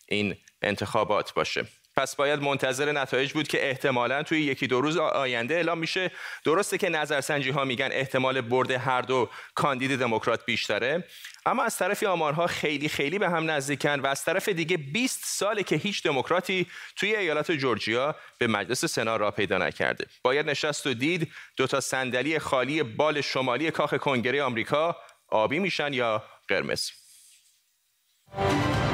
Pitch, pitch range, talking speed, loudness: 140 Hz, 130-160 Hz, 150 wpm, -27 LUFS